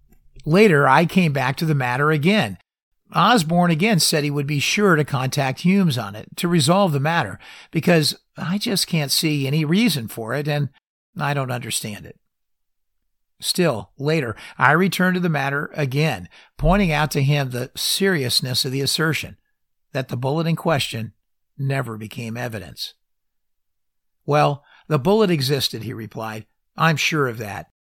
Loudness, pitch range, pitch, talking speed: -20 LUFS, 120-165 Hz, 145 Hz, 155 wpm